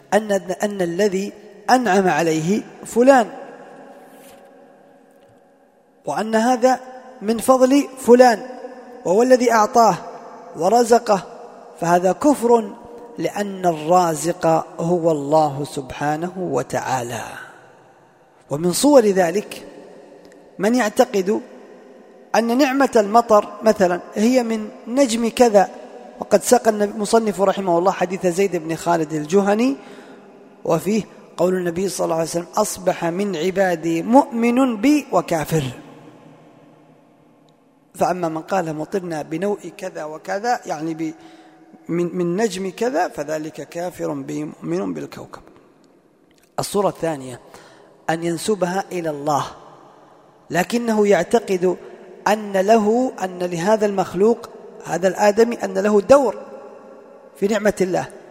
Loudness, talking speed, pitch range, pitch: -19 LUFS, 100 wpm, 175-235 Hz, 200 Hz